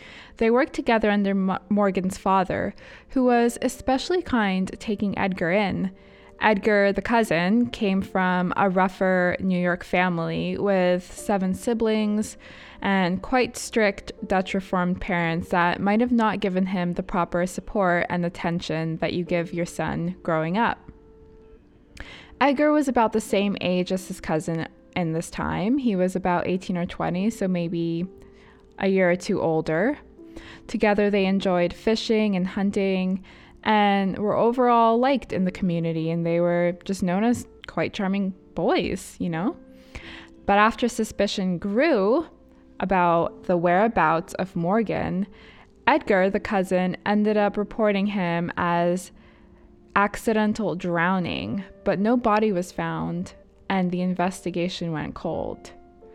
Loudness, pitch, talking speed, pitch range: -24 LUFS, 190 Hz, 135 wpm, 175-215 Hz